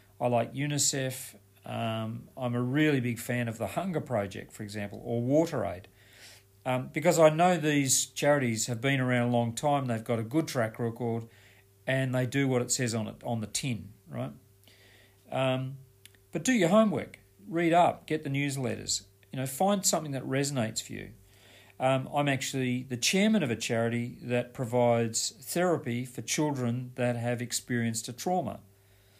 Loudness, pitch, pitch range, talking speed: -29 LUFS, 120 Hz, 110-140 Hz, 170 wpm